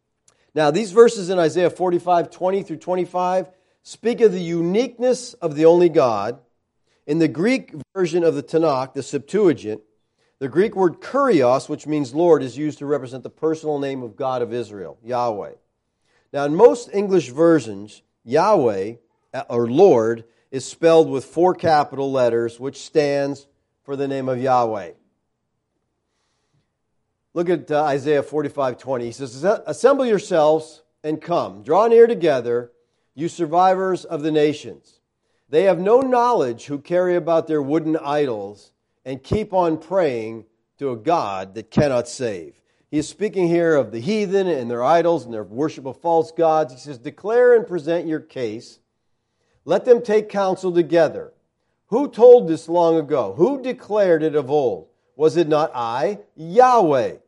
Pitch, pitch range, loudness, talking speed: 155 Hz, 135-180 Hz, -19 LUFS, 155 wpm